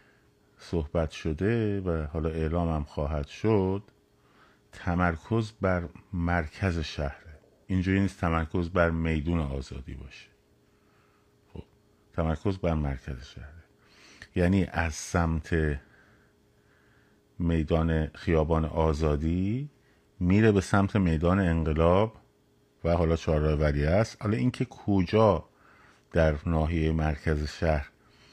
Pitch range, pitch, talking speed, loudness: 80-95 Hz, 85 Hz, 95 wpm, -28 LUFS